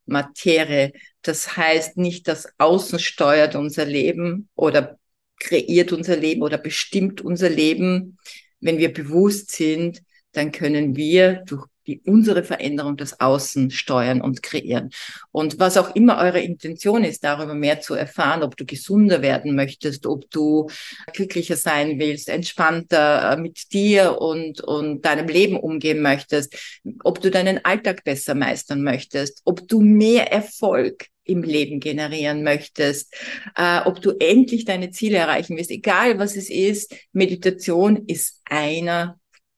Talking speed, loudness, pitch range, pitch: 140 wpm, -20 LUFS, 150-190 Hz, 165 Hz